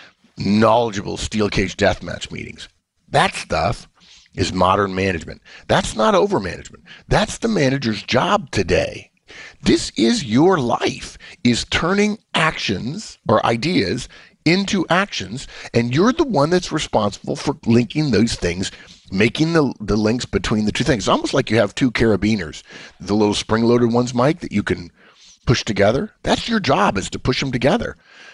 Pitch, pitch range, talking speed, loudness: 115 Hz, 100-140 Hz, 155 wpm, -19 LUFS